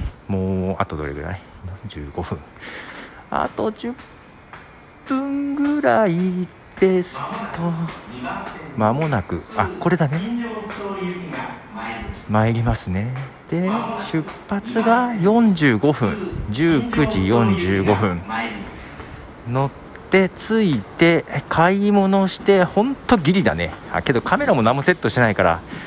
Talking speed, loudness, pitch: 175 characters per minute, -20 LUFS, 160 Hz